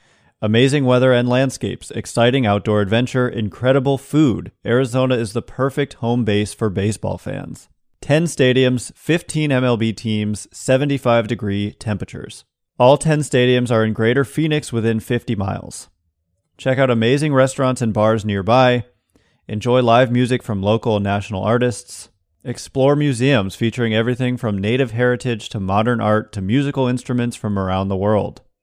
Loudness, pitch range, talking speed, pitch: -18 LUFS, 105-130 Hz, 145 wpm, 120 Hz